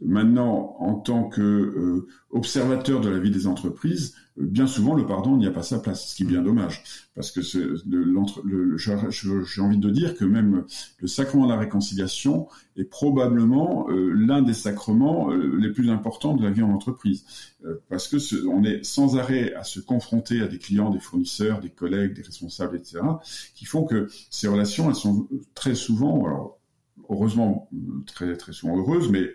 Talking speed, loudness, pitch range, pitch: 200 wpm, -24 LUFS, 95-125 Hz, 105 Hz